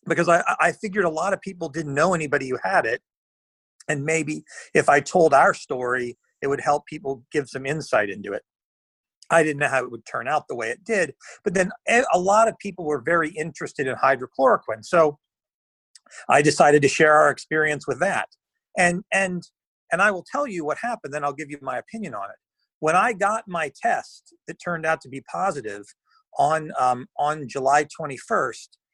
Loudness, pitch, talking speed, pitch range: -22 LUFS, 160 Hz, 195 wpm, 145-195 Hz